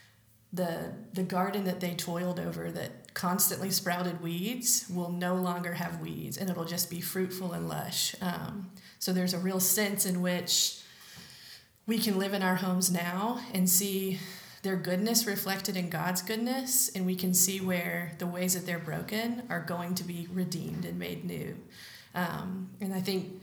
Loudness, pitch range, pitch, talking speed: -31 LUFS, 175-190 Hz, 180 Hz, 175 wpm